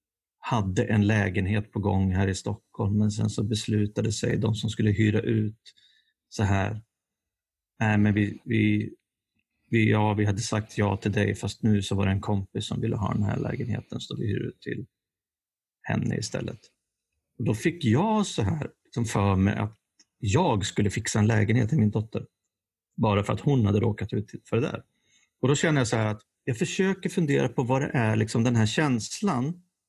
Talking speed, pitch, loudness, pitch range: 200 wpm, 110 Hz, -26 LUFS, 105-120 Hz